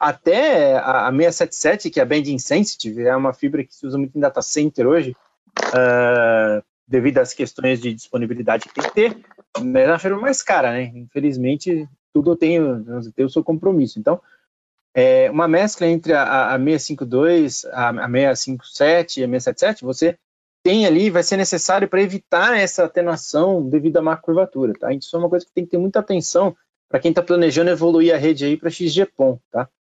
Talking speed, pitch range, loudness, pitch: 185 wpm, 135-185 Hz, -18 LUFS, 165 Hz